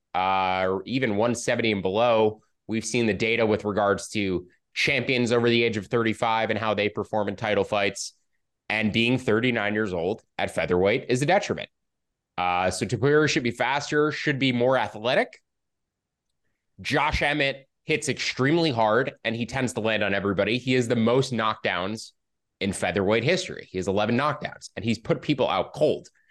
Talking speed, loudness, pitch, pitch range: 175 wpm, -24 LUFS, 110 Hz, 105-125 Hz